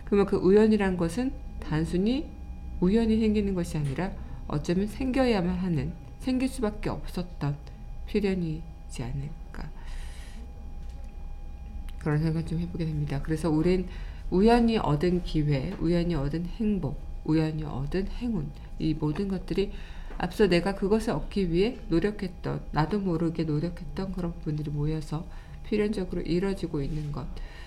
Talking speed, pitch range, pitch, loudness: 295 characters per minute, 150-195 Hz, 170 Hz, -28 LUFS